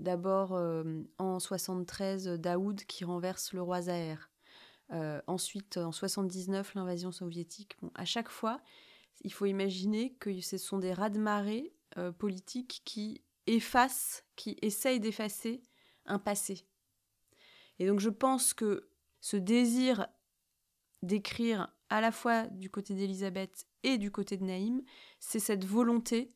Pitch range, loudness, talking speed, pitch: 185-230 Hz, -35 LUFS, 140 wpm, 200 Hz